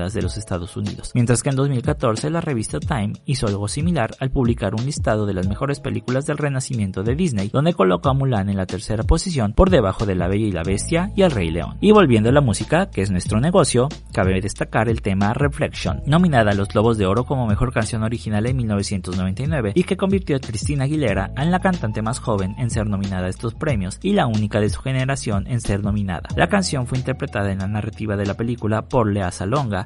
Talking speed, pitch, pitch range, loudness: 225 wpm, 115 Hz, 100-140 Hz, -20 LUFS